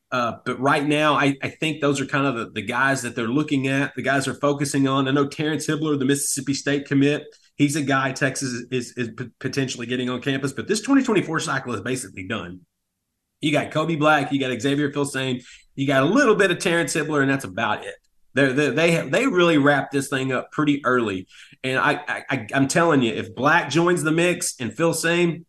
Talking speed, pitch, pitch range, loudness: 225 wpm, 140 Hz, 130-150 Hz, -22 LUFS